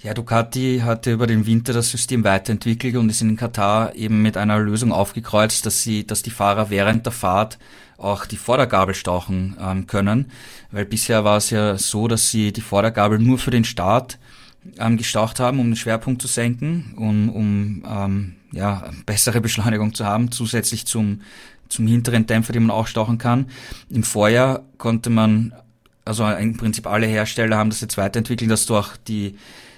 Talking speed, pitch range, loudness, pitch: 185 wpm, 105-115 Hz, -19 LUFS, 110 Hz